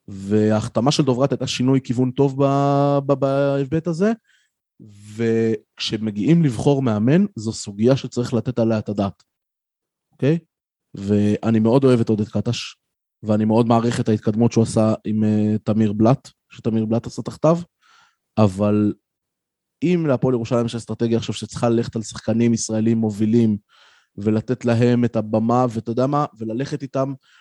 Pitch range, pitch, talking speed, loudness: 110-135 Hz, 115 Hz, 140 wpm, -20 LUFS